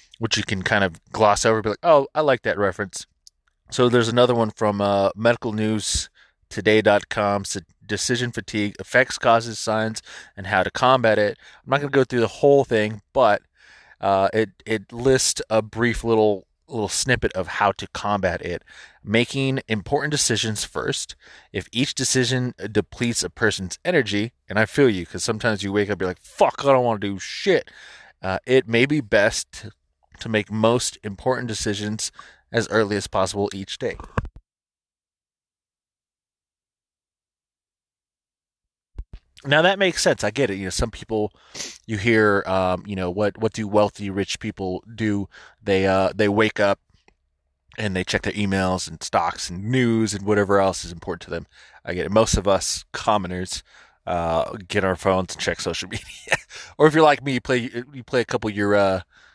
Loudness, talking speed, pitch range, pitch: -22 LUFS, 180 wpm, 95-115 Hz, 105 Hz